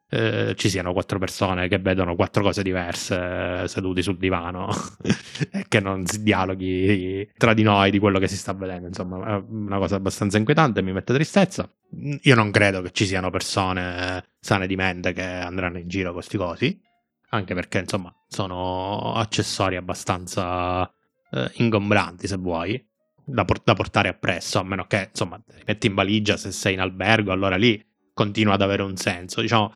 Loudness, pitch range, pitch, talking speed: -23 LUFS, 95-110 Hz, 100 Hz, 180 wpm